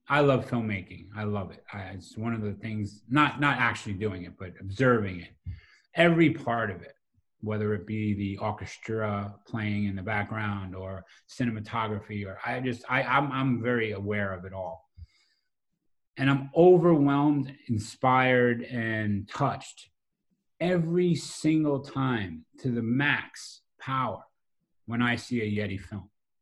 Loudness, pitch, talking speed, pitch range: -28 LUFS, 110 Hz, 140 wpm, 100-130 Hz